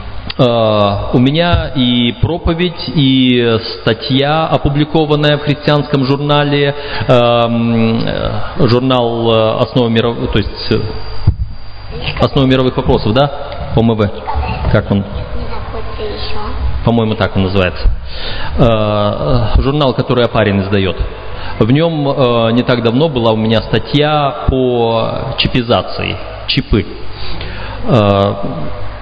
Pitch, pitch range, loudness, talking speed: 115 Hz, 105-130 Hz, -13 LUFS, 85 wpm